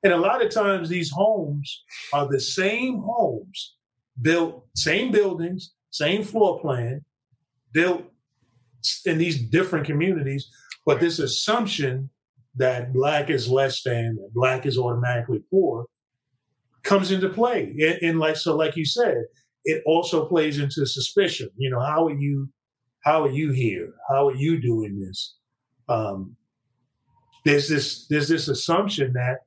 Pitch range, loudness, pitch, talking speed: 125-170 Hz, -23 LUFS, 145 Hz, 140 wpm